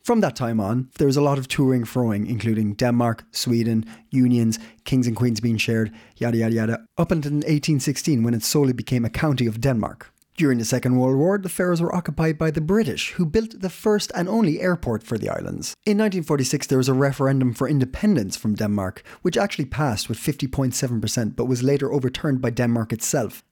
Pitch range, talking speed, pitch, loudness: 115-155 Hz, 200 wpm, 130 Hz, -22 LUFS